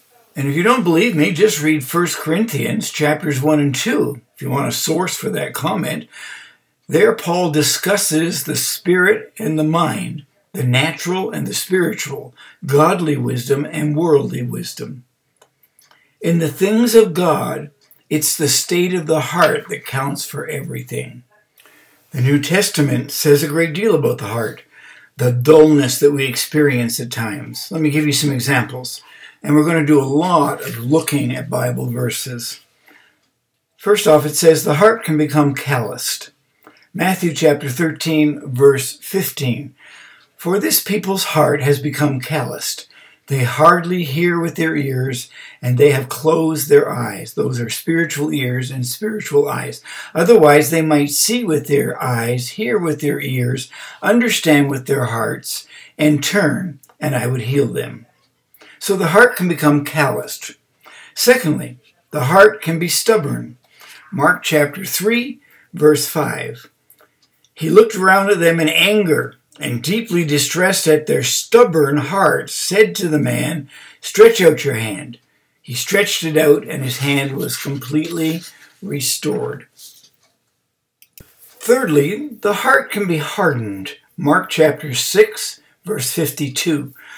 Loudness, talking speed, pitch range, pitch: -16 LUFS, 145 wpm, 140-180 Hz, 155 Hz